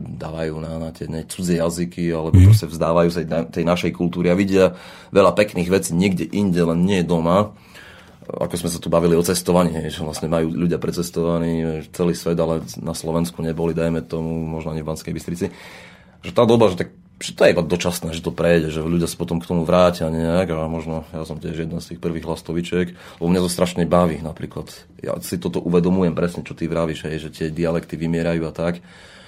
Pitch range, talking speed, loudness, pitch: 80-90 Hz, 210 wpm, -20 LUFS, 85 Hz